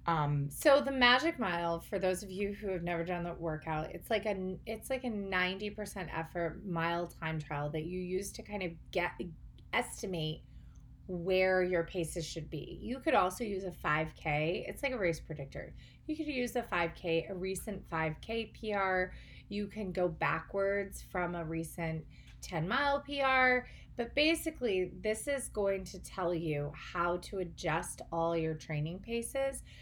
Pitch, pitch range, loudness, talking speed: 185 Hz, 165-215 Hz, -35 LUFS, 170 wpm